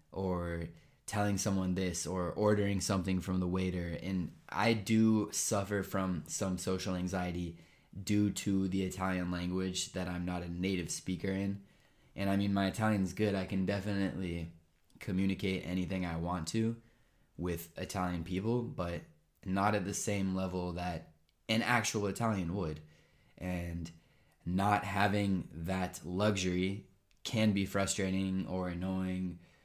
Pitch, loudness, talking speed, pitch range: 95 Hz, -35 LUFS, 140 wpm, 90-100 Hz